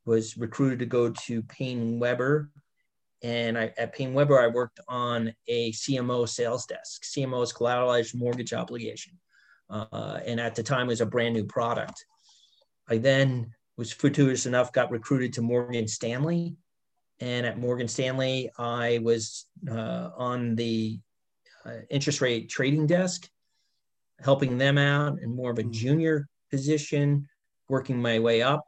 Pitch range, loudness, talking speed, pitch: 115-140 Hz, -27 LUFS, 150 wpm, 125 Hz